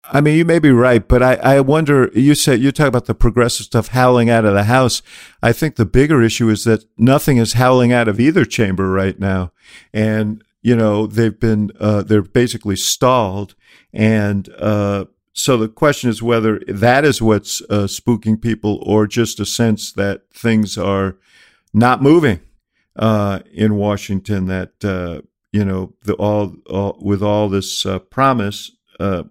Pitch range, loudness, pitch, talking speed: 100-120 Hz, -15 LUFS, 110 Hz, 175 wpm